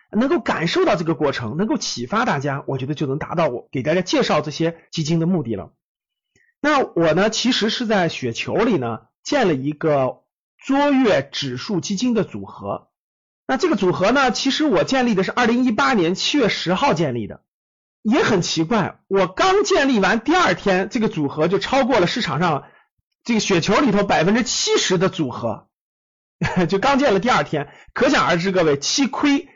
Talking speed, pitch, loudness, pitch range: 280 characters per minute, 195 Hz, -19 LUFS, 155-250 Hz